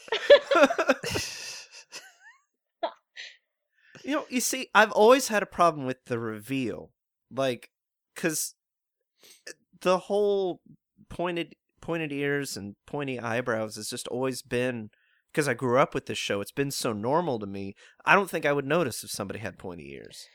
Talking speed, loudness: 145 wpm, -27 LUFS